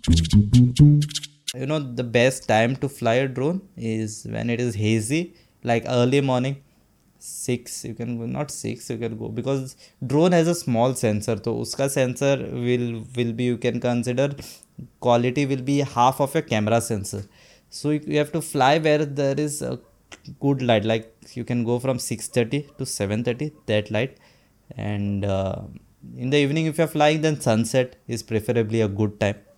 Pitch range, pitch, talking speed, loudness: 115-140 Hz, 125 Hz, 175 wpm, -23 LUFS